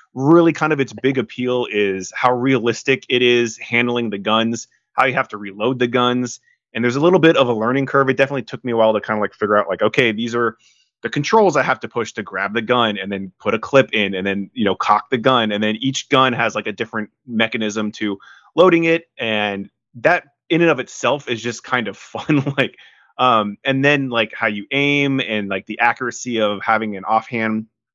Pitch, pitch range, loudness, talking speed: 120 Hz, 110-135 Hz, -18 LUFS, 230 wpm